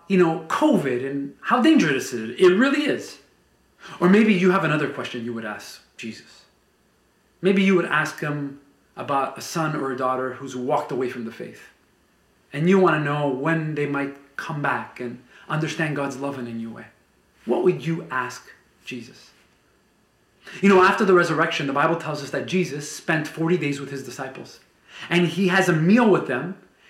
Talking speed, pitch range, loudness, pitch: 190 wpm, 140-185 Hz, -22 LUFS, 155 Hz